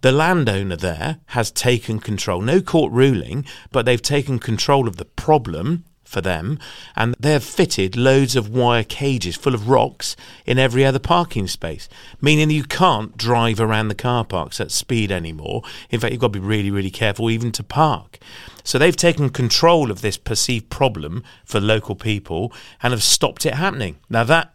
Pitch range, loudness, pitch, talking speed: 105-140 Hz, -19 LUFS, 120 Hz, 180 wpm